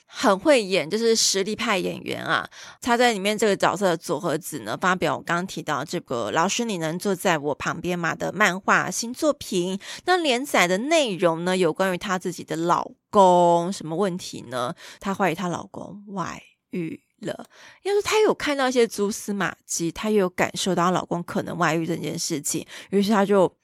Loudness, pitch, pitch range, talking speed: -23 LUFS, 190 Hz, 170-215 Hz, 285 characters per minute